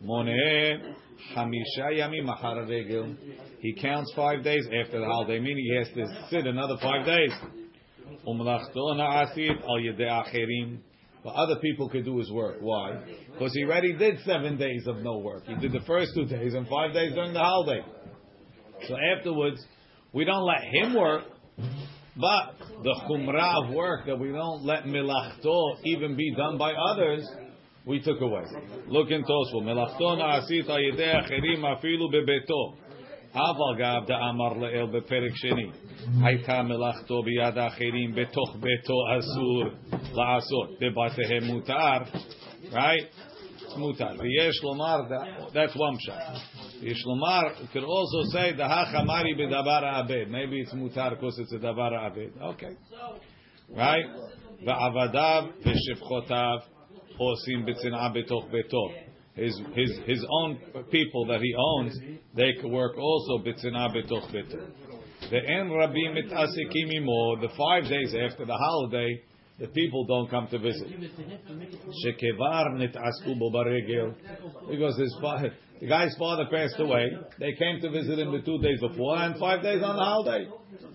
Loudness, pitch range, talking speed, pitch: -28 LUFS, 120-155 Hz, 125 wpm, 130 Hz